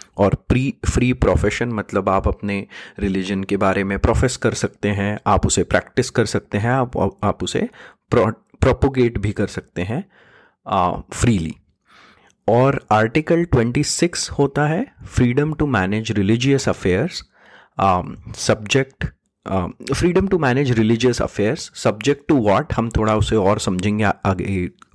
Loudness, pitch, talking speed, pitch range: -19 LUFS, 110 Hz, 130 wpm, 100-130 Hz